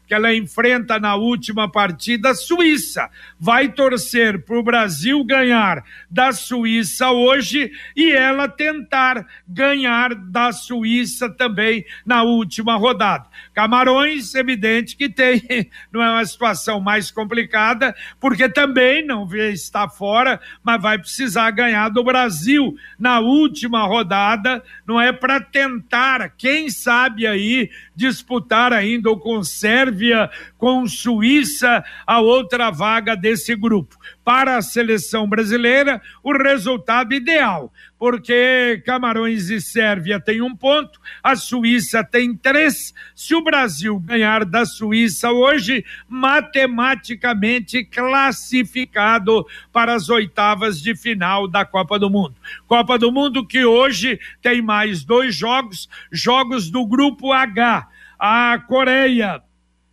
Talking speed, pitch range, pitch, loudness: 120 wpm, 220-255 Hz, 235 Hz, -16 LUFS